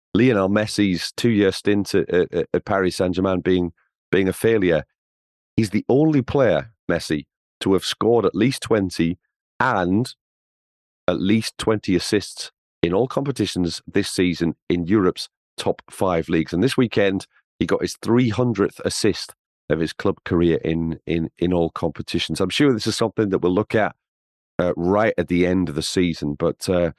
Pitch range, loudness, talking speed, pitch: 85-110 Hz, -21 LUFS, 165 wpm, 95 Hz